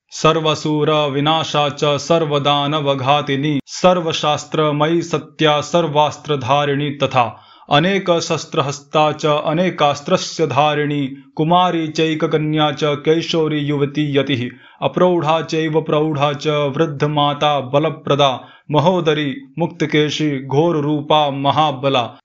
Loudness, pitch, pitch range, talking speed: -17 LUFS, 150 Hz, 145-160 Hz, 65 wpm